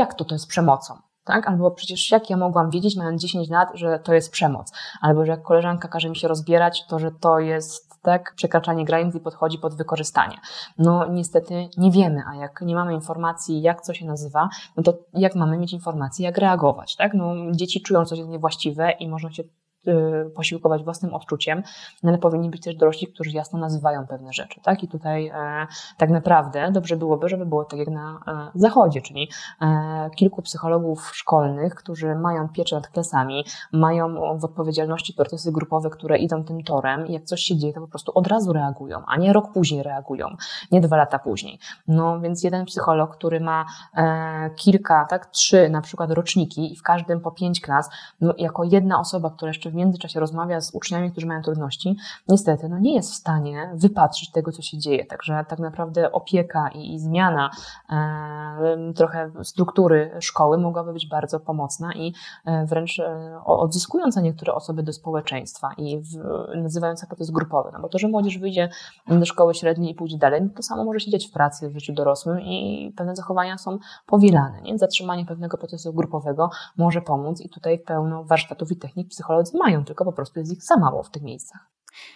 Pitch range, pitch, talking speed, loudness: 155-175 Hz, 165 Hz, 190 wpm, -22 LUFS